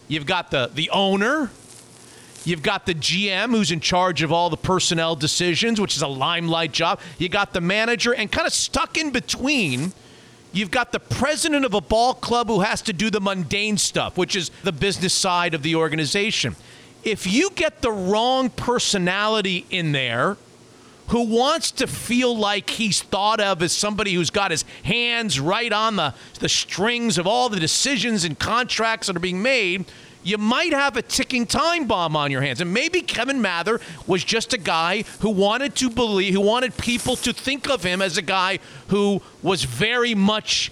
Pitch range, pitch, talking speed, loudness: 175-235 Hz, 200 Hz, 190 wpm, -21 LUFS